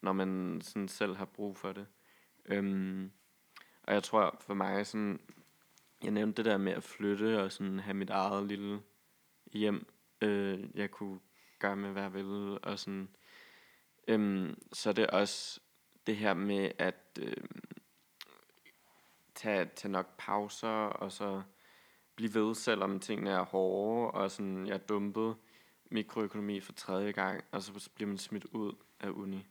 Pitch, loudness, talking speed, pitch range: 100 Hz, -36 LUFS, 155 wpm, 95-105 Hz